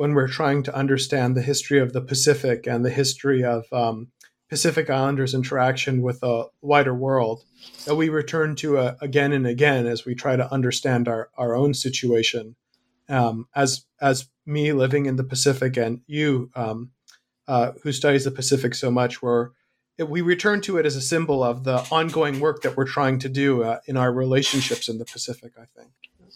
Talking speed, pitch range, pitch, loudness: 190 wpm, 125-145 Hz, 130 Hz, -22 LUFS